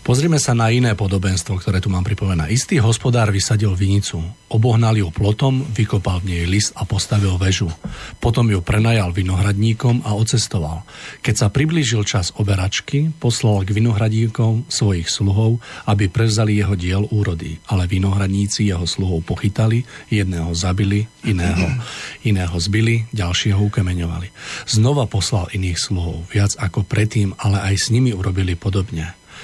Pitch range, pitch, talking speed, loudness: 95-115 Hz, 105 Hz, 140 wpm, -18 LUFS